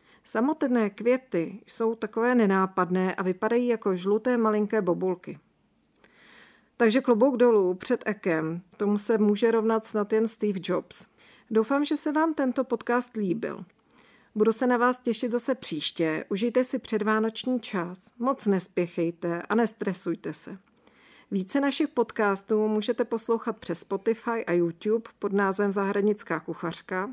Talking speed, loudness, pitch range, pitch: 135 wpm, -26 LUFS, 195-240 Hz, 220 Hz